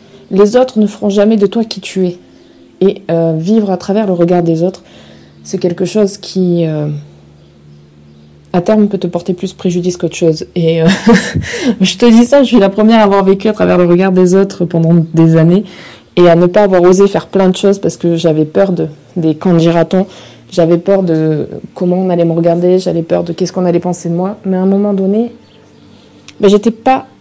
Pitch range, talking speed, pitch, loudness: 165-200 Hz, 215 wpm, 180 Hz, -11 LUFS